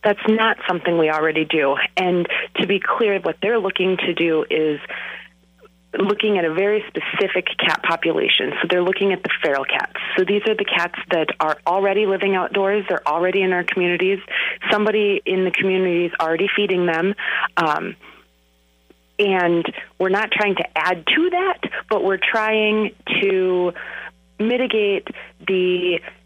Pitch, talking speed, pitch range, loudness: 190 Hz, 155 wpm, 175-205 Hz, -19 LUFS